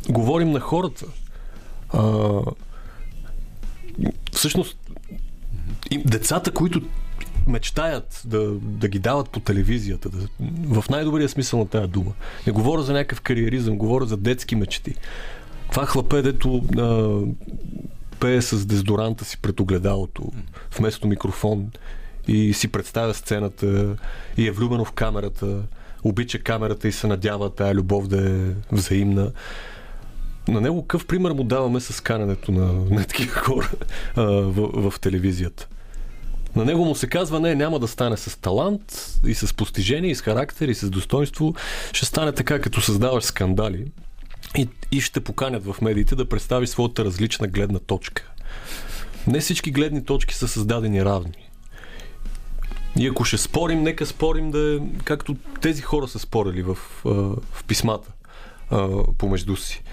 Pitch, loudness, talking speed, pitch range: 110 Hz, -23 LUFS, 140 wpm, 100-135 Hz